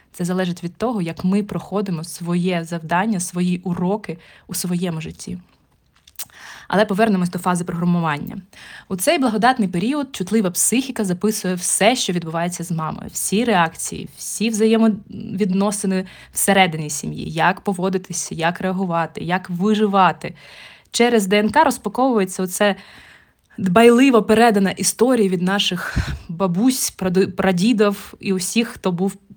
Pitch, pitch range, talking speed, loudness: 190 Hz, 180-215 Hz, 120 wpm, -19 LUFS